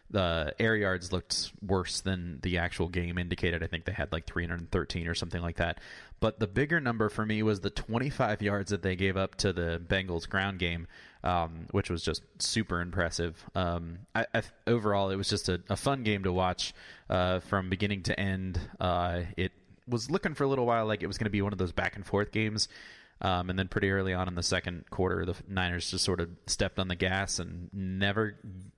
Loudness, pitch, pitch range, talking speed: -31 LUFS, 95 Hz, 90-105 Hz, 220 wpm